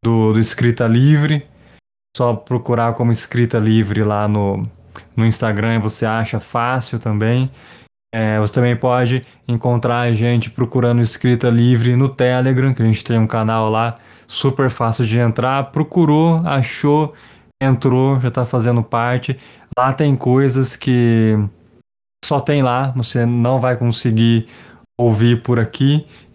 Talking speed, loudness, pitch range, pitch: 140 wpm, -16 LUFS, 115-130 Hz, 120 Hz